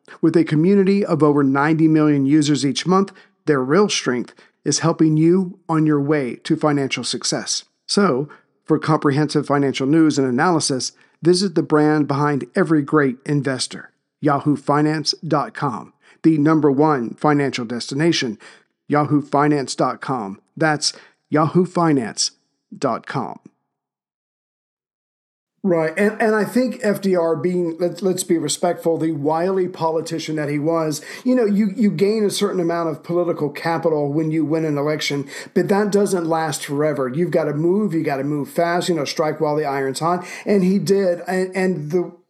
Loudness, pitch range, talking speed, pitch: -19 LUFS, 145-180 Hz, 150 wpm, 160 Hz